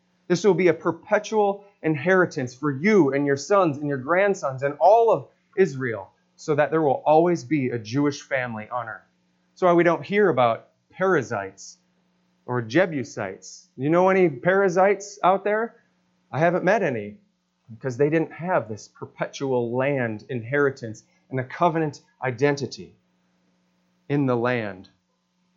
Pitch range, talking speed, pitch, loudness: 120-180 Hz, 150 wpm, 145 Hz, -23 LUFS